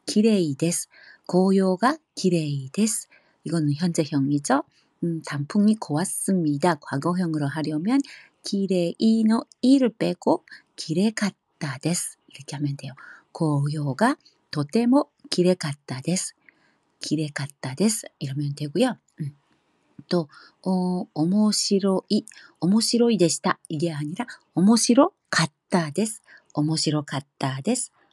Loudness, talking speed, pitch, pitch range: -24 LUFS, 230 characters per minute, 175 Hz, 150-210 Hz